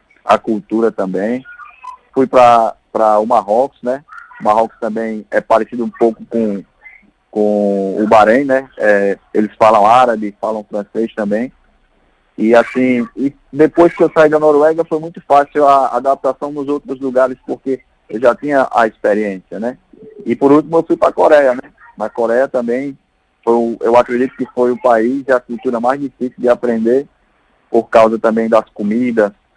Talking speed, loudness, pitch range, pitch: 165 wpm, -14 LUFS, 110-135 Hz, 120 Hz